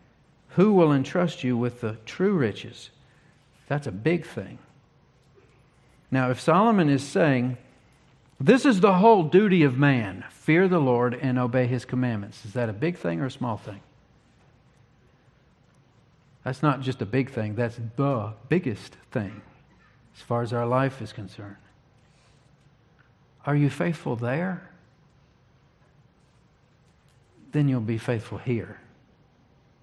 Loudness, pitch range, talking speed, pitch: -24 LUFS, 120-150 Hz, 135 wpm, 130 Hz